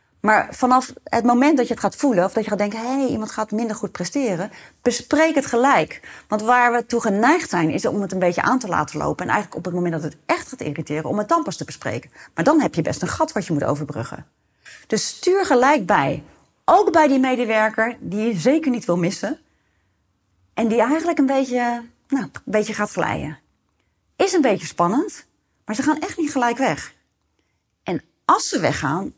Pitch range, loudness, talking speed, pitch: 195-275 Hz, -20 LUFS, 215 wpm, 235 Hz